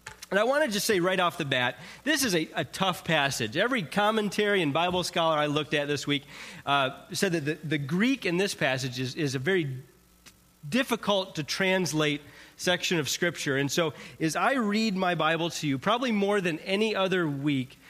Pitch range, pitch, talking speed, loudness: 150-195 Hz, 170 Hz, 200 wpm, -27 LUFS